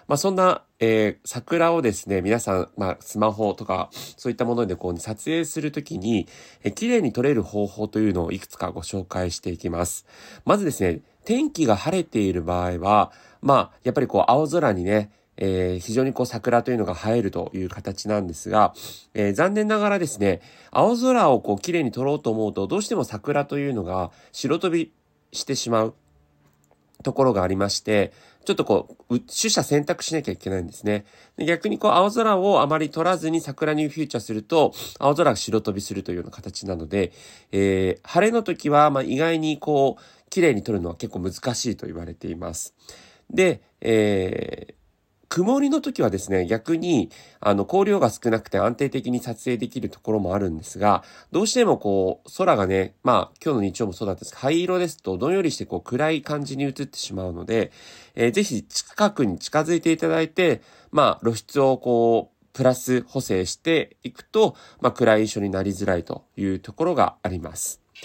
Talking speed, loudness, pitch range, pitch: 370 characters per minute, -23 LUFS, 95-155 Hz, 115 Hz